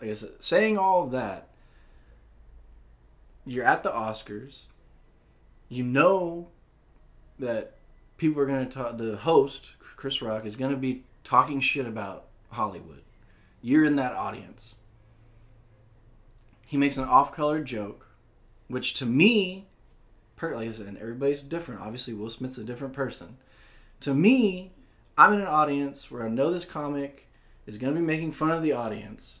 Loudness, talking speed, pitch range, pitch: -26 LUFS, 150 wpm, 110-140 Hz, 125 Hz